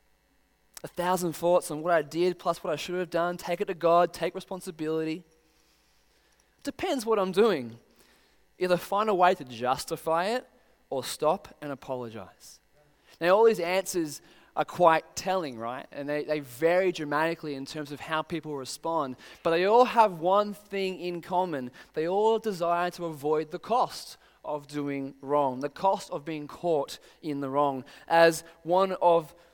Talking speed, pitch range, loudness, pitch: 165 wpm, 150-185 Hz, -28 LUFS, 170 Hz